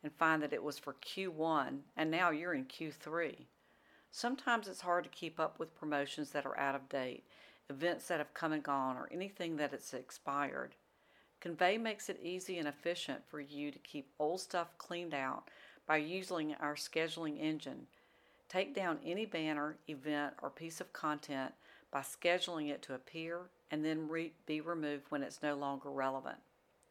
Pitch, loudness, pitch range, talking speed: 155 Hz, -40 LUFS, 145-175 Hz, 175 wpm